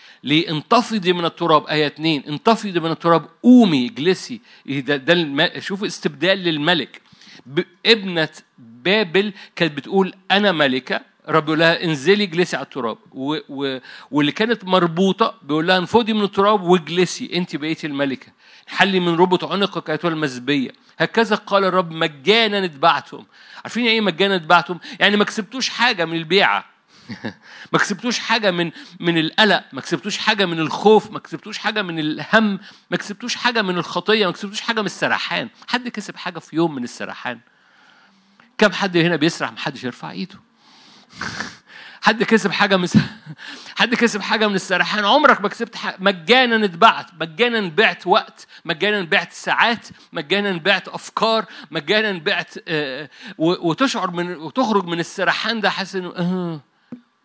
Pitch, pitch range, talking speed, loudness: 185 Hz, 165-215 Hz, 140 wpm, -18 LUFS